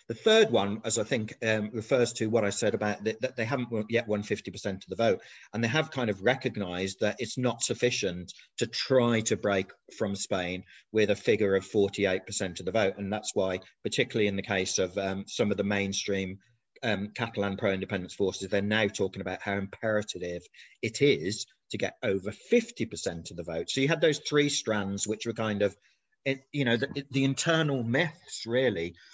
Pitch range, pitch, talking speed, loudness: 100-120 Hz, 105 Hz, 200 wpm, -29 LUFS